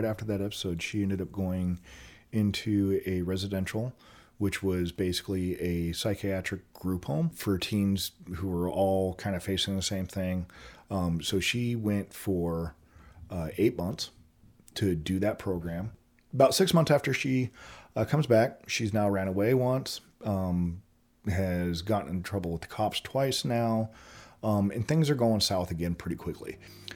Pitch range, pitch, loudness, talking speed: 90-110 Hz, 95 Hz, -30 LUFS, 160 wpm